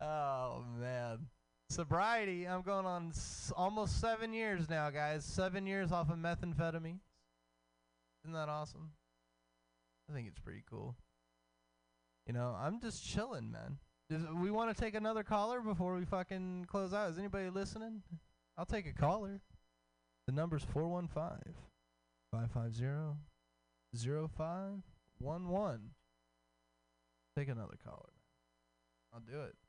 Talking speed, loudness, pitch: 125 wpm, -41 LUFS, 150 Hz